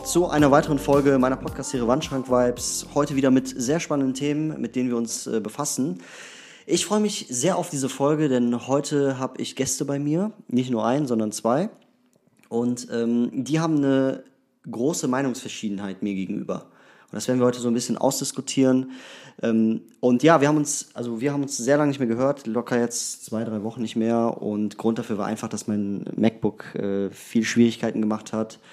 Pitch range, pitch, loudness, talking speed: 115-140 Hz, 125 Hz, -24 LUFS, 190 wpm